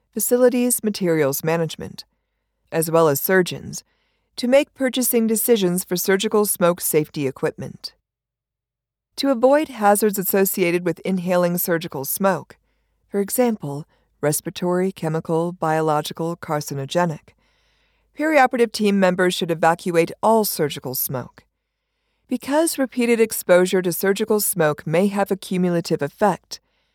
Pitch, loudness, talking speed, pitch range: 185 Hz, -20 LUFS, 110 wpm, 160-220 Hz